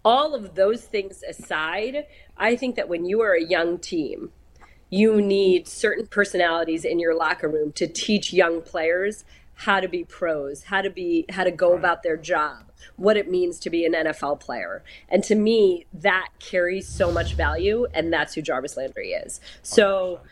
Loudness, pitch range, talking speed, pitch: -23 LUFS, 170-210 Hz, 185 wpm, 185 Hz